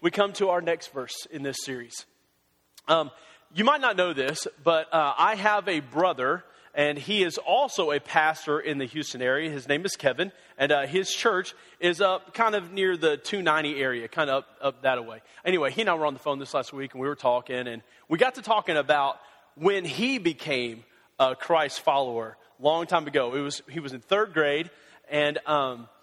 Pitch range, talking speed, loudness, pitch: 135-180 Hz, 215 wpm, -26 LUFS, 150 Hz